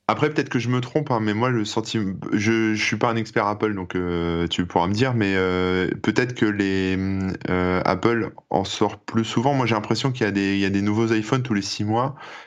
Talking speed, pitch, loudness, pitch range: 250 wpm, 110 Hz, -22 LUFS, 95-115 Hz